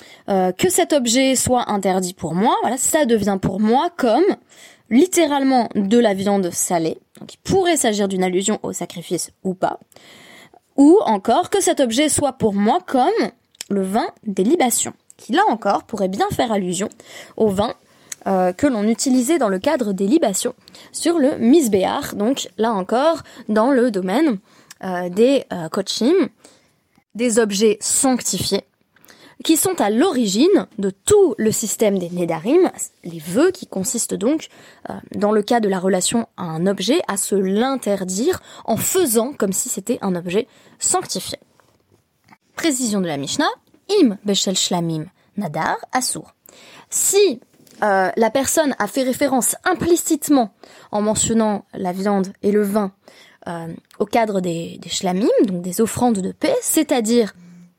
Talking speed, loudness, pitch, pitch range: 155 wpm, -18 LUFS, 225 Hz, 195-275 Hz